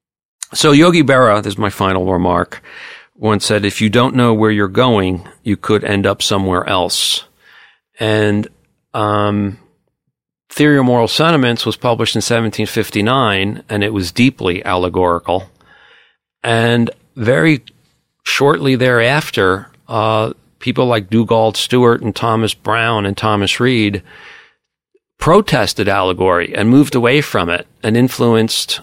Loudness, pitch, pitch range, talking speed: -14 LUFS, 110 Hz, 100-120 Hz, 130 wpm